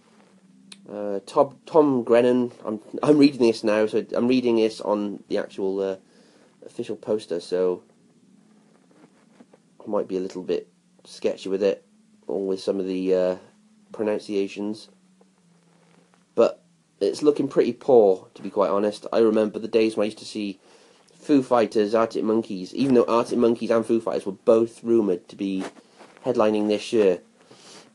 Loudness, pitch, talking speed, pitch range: -23 LUFS, 115 Hz, 155 wpm, 105-170 Hz